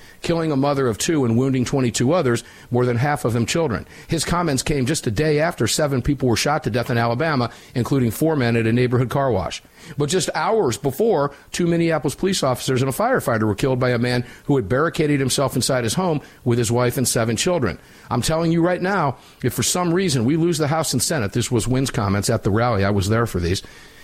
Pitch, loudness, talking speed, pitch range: 130 Hz, -20 LUFS, 235 wpm, 120-155 Hz